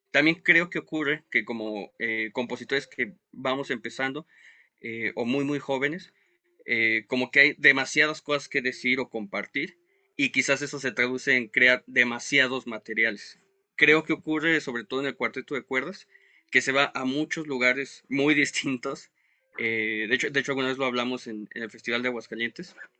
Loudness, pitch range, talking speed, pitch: -25 LUFS, 120-150 Hz, 175 wpm, 130 Hz